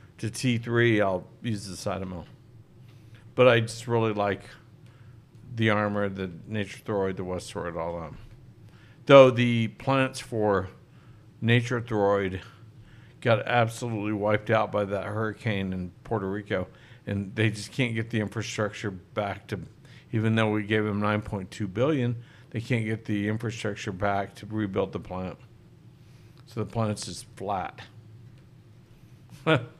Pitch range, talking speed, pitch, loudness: 105-120 Hz, 140 wpm, 110 Hz, -27 LUFS